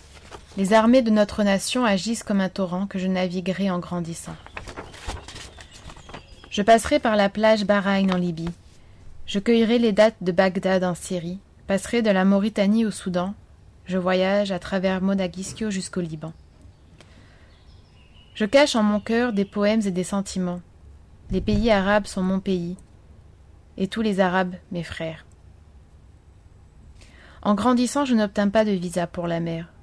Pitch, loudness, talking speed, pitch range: 190 Hz, -22 LUFS, 150 wpm, 160-210 Hz